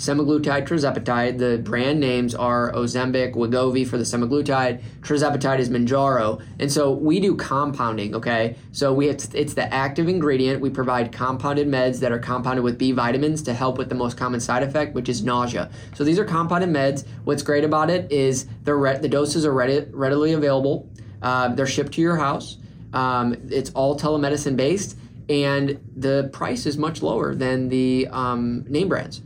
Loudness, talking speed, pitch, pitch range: -22 LUFS, 175 wpm, 130 Hz, 125-145 Hz